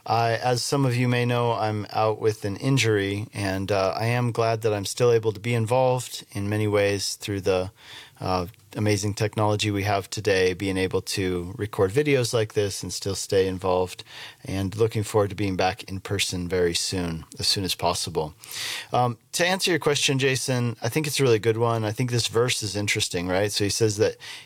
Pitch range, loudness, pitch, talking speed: 100-120 Hz, -24 LUFS, 110 Hz, 205 wpm